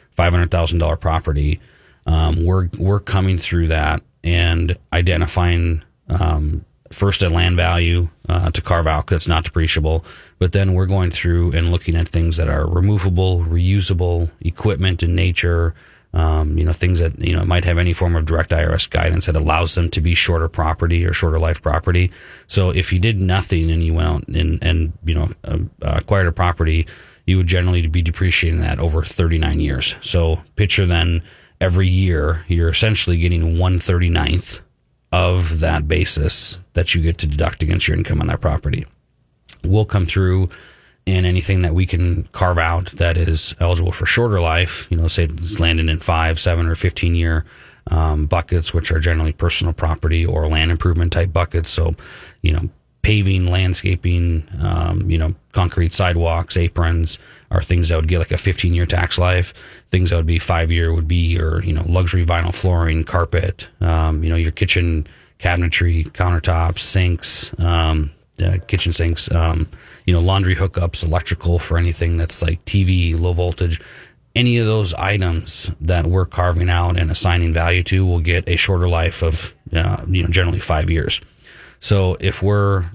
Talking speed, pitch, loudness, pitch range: 175 wpm, 85 Hz, -18 LUFS, 80-90 Hz